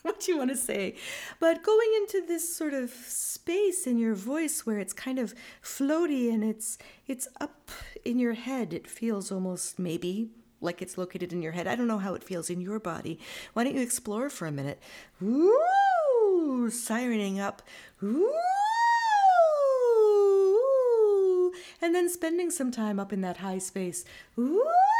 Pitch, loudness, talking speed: 260 Hz, -28 LUFS, 165 wpm